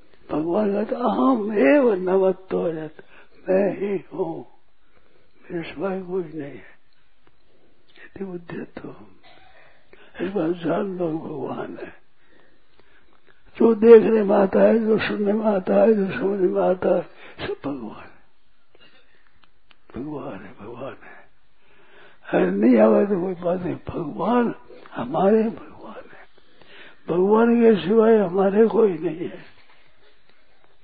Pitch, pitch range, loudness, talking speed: 195 Hz, 180-220 Hz, -20 LUFS, 125 wpm